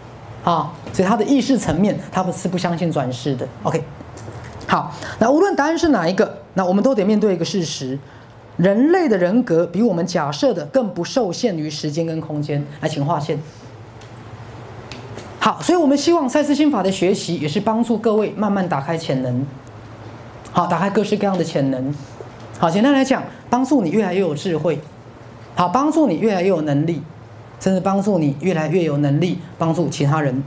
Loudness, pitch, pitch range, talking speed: -19 LUFS, 170 Hz, 140-210 Hz, 280 characters per minute